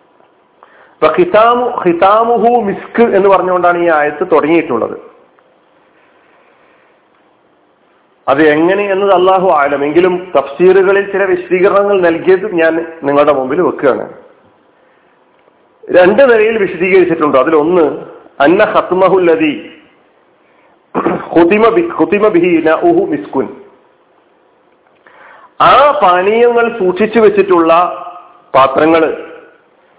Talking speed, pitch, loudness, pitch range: 65 wpm, 185 Hz, -10 LUFS, 170-230 Hz